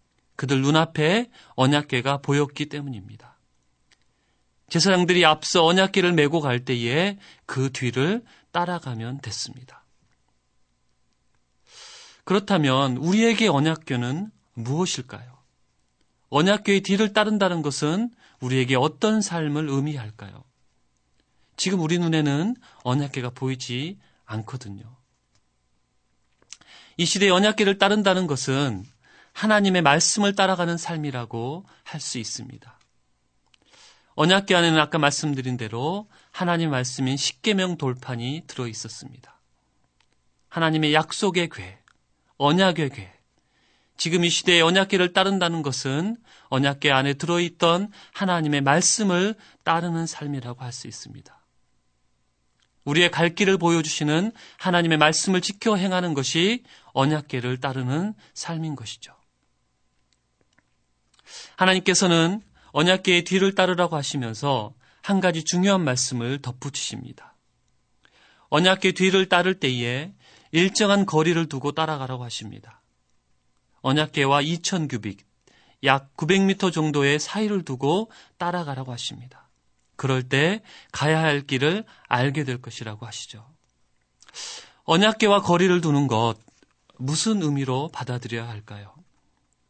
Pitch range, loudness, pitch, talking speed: 125-180 Hz, -22 LUFS, 145 Hz, 265 characters per minute